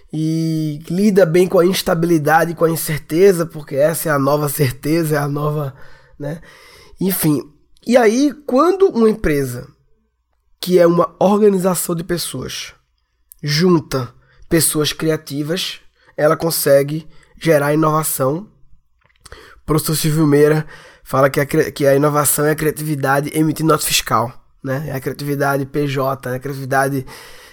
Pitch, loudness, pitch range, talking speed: 155 Hz, -16 LUFS, 140-170 Hz, 135 wpm